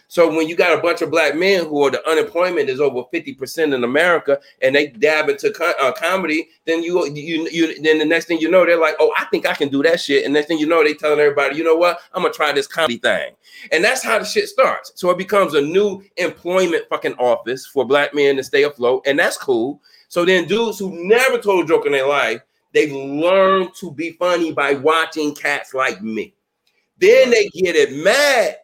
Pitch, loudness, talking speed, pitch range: 170 Hz, -17 LUFS, 235 wpm, 155-215 Hz